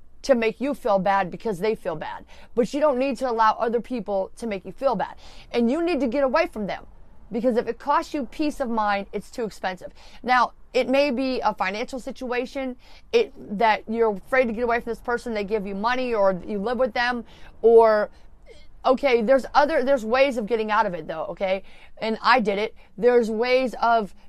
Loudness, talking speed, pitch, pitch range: -23 LUFS, 215 wpm, 240 Hz, 215-265 Hz